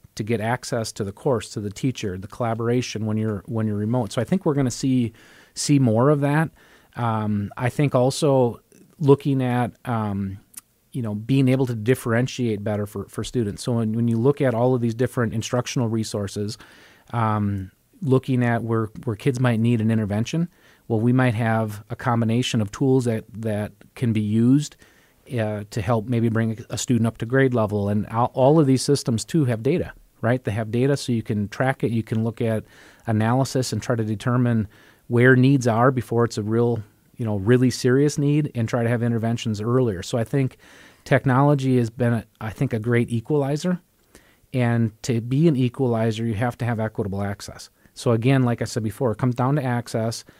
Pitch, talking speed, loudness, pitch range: 120 Hz, 200 wpm, -22 LUFS, 110-130 Hz